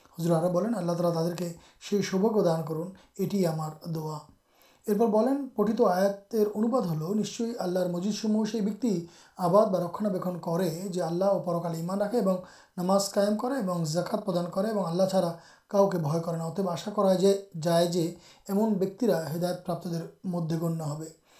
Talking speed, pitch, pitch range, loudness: 110 wpm, 185 Hz, 170-205 Hz, -28 LUFS